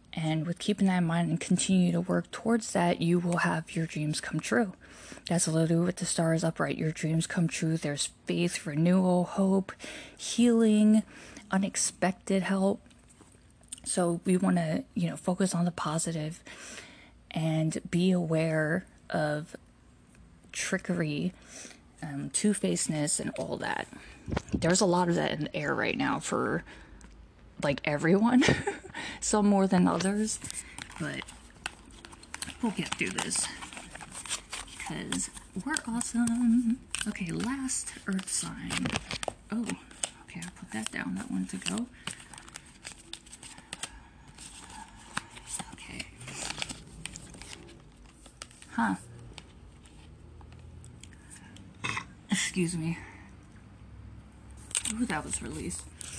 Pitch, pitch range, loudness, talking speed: 175 Hz, 150-195 Hz, -30 LUFS, 110 wpm